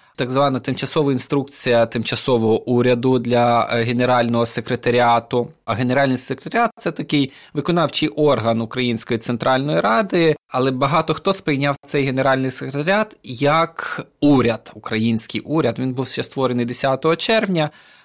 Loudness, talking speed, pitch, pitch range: -19 LUFS, 120 wpm, 130 Hz, 120-145 Hz